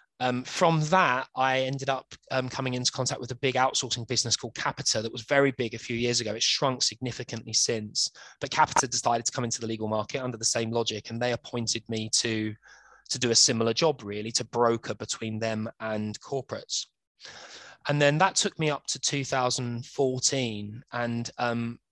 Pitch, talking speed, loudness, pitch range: 120 Hz, 190 wpm, -27 LUFS, 115-130 Hz